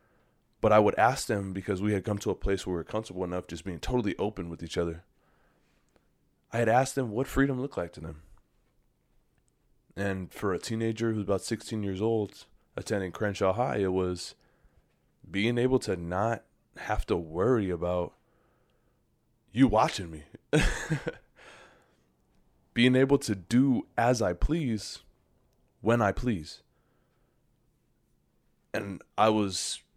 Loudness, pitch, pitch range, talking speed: -29 LUFS, 105 Hz, 90-120 Hz, 145 wpm